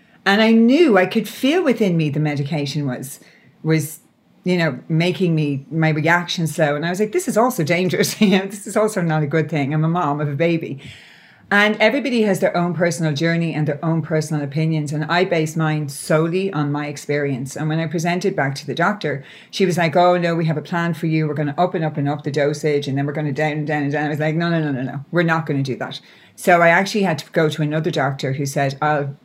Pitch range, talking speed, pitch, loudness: 150-180 Hz, 260 wpm, 160 Hz, -19 LUFS